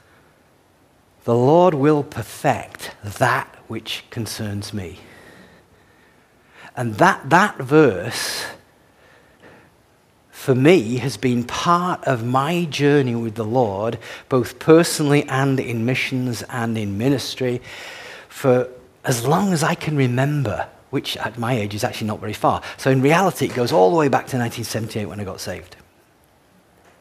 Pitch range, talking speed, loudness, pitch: 115-145 Hz, 140 wpm, -20 LUFS, 125 Hz